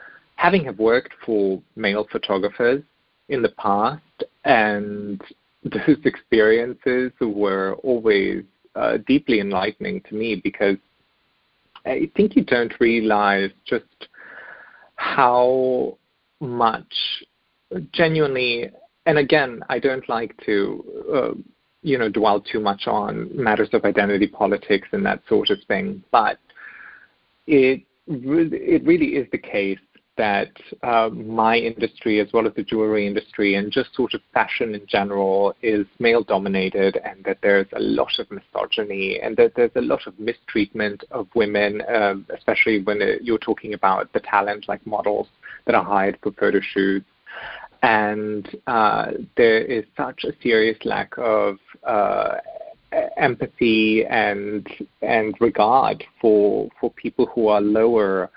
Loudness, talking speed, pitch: -21 LUFS, 135 wpm, 110 Hz